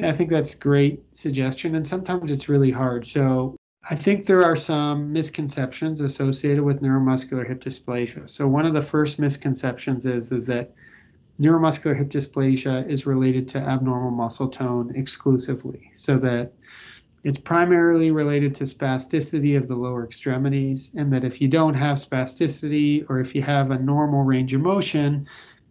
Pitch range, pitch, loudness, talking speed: 130-150 Hz, 140 Hz, -22 LUFS, 160 wpm